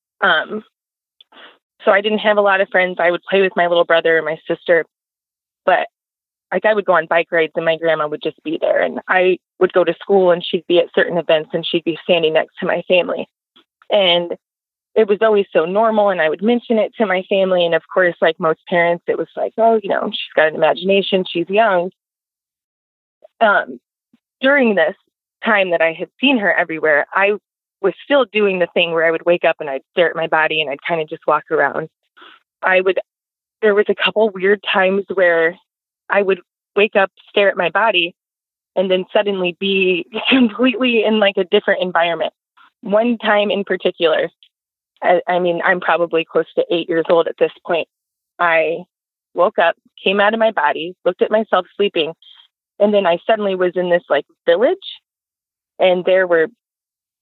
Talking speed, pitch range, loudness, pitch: 200 wpm, 170-210 Hz, -16 LUFS, 185 Hz